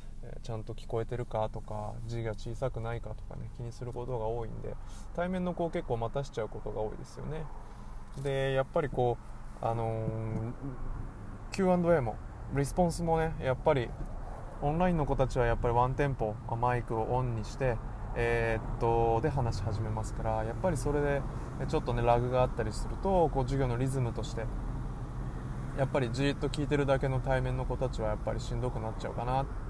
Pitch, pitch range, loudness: 120 Hz, 110-135 Hz, -33 LUFS